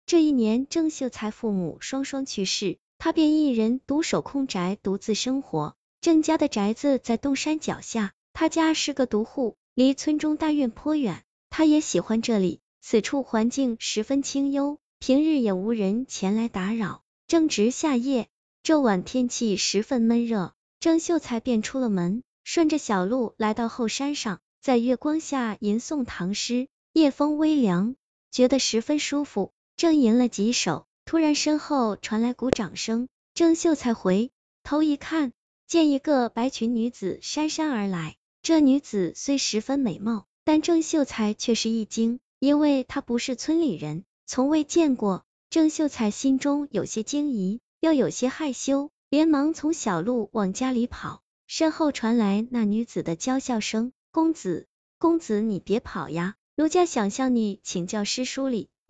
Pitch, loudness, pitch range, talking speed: 255 Hz, -25 LUFS, 220-295 Hz, 230 characters per minute